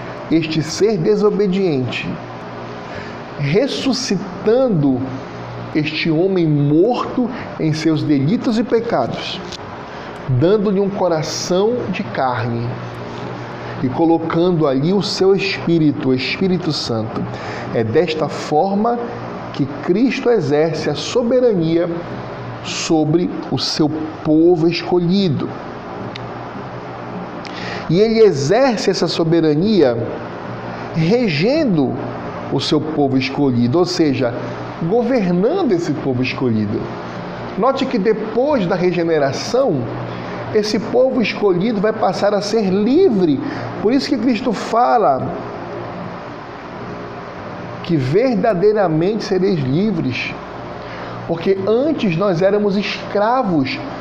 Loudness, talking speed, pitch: -17 LUFS, 90 wpm, 165 Hz